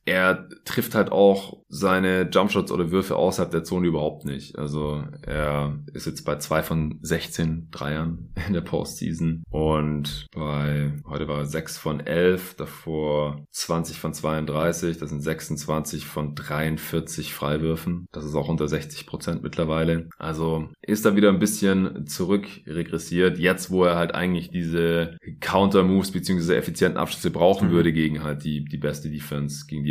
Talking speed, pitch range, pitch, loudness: 155 wpm, 75-85 Hz, 80 Hz, -24 LUFS